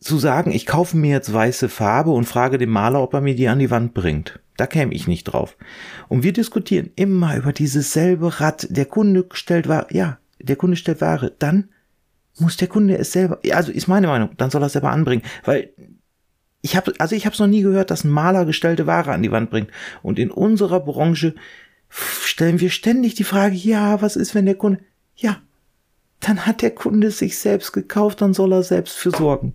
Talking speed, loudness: 220 wpm, -18 LUFS